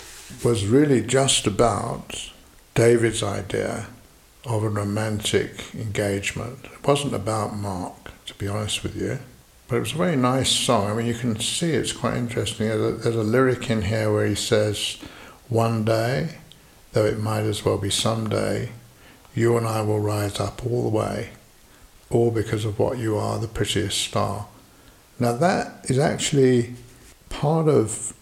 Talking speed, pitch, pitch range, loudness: 165 wpm, 110 Hz, 105-120 Hz, -23 LUFS